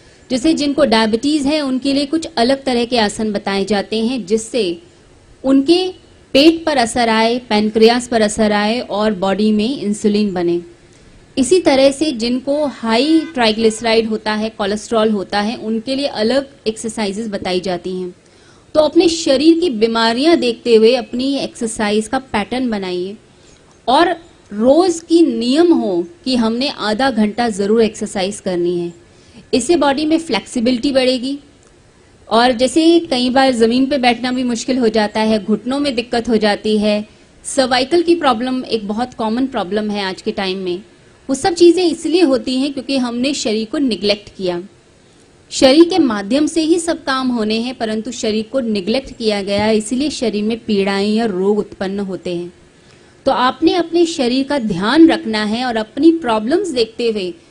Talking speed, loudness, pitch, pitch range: 165 wpm, -15 LUFS, 235 Hz, 215-275 Hz